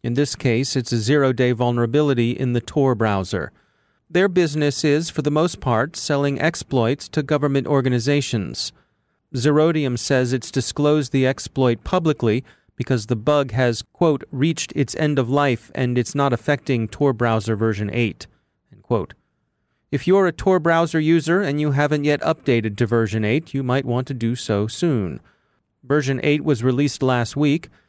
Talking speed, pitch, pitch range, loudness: 165 wpm, 135 Hz, 120-150 Hz, -20 LUFS